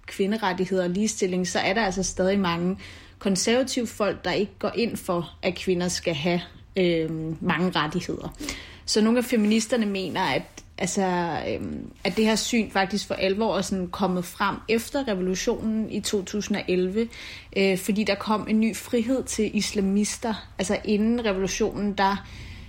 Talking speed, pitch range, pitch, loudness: 155 wpm, 185-215 Hz, 200 Hz, -25 LUFS